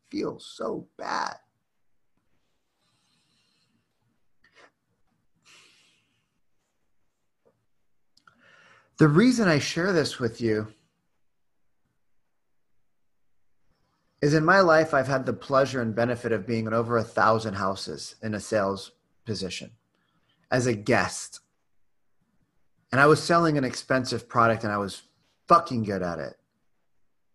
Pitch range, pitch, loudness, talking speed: 110-140 Hz, 120 Hz, -25 LUFS, 105 wpm